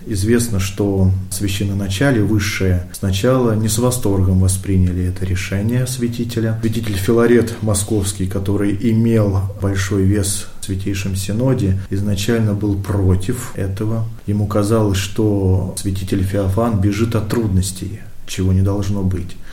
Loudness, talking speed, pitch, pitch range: -18 LUFS, 115 wpm, 100 Hz, 95-110 Hz